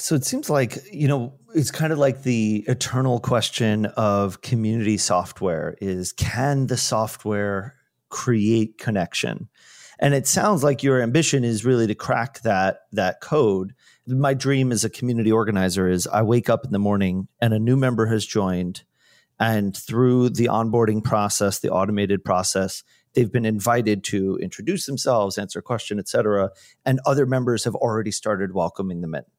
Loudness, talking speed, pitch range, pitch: -22 LUFS, 165 wpm, 100-130 Hz, 115 Hz